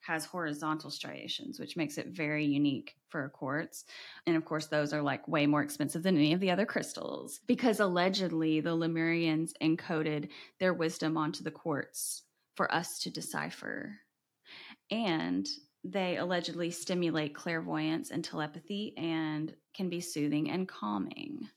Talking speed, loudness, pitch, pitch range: 145 wpm, -34 LUFS, 160 Hz, 150-175 Hz